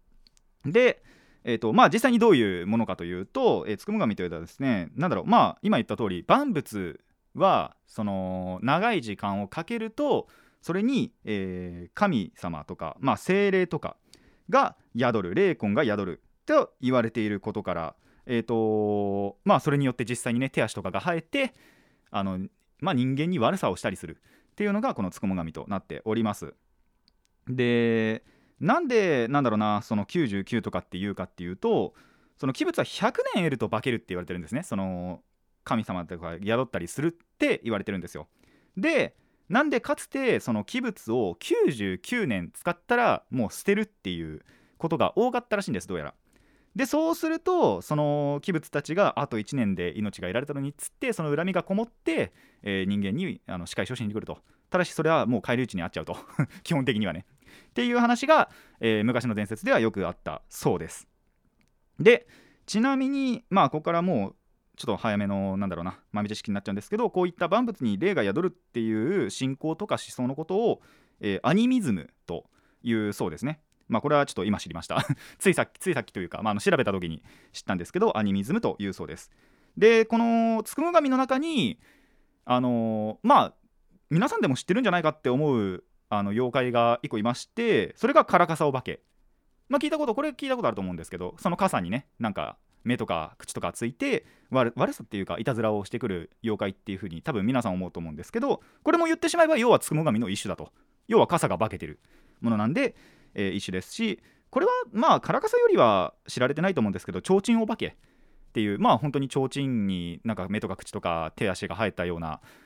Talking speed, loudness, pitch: 390 characters per minute, -27 LUFS, 125 Hz